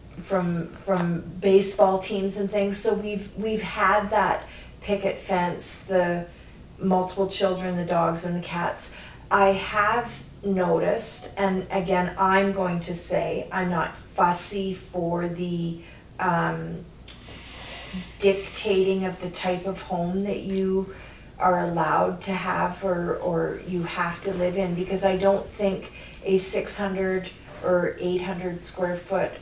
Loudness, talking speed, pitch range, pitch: -25 LUFS, 135 wpm, 175-195 Hz, 185 Hz